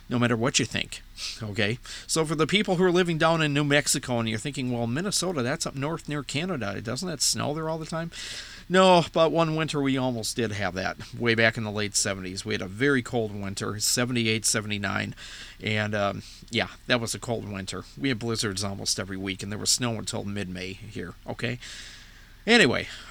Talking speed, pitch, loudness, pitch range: 210 wpm, 115 Hz, -26 LUFS, 105-145 Hz